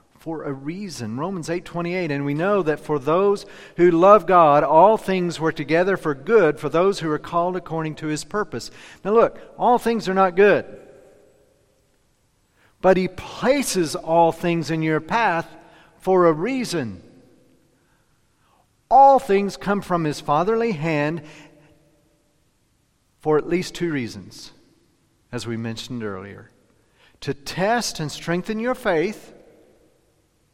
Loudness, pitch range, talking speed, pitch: -20 LUFS, 150-190 Hz, 135 wpm, 165 Hz